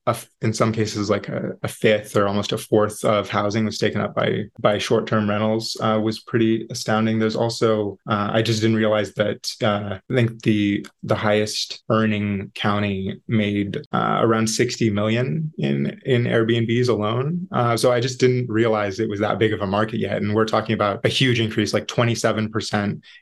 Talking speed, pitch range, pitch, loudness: 195 wpm, 105-115 Hz, 110 Hz, -21 LUFS